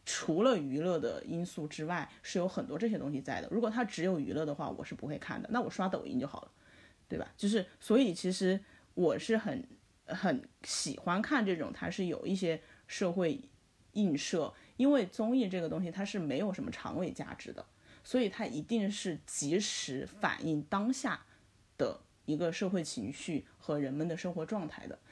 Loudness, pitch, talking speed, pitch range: -35 LUFS, 195 Hz, 275 characters per minute, 170-230 Hz